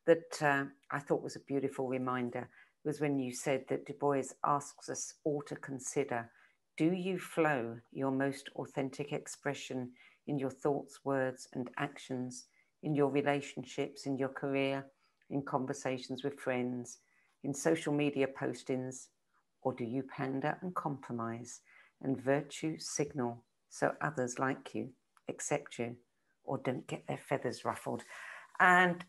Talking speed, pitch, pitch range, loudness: 140 wpm, 135 Hz, 130-145 Hz, -36 LUFS